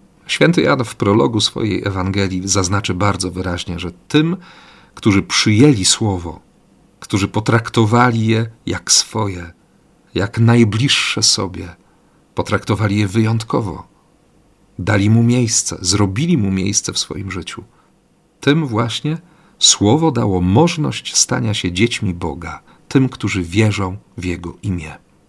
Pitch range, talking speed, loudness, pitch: 95-115 Hz, 115 wpm, -16 LUFS, 105 Hz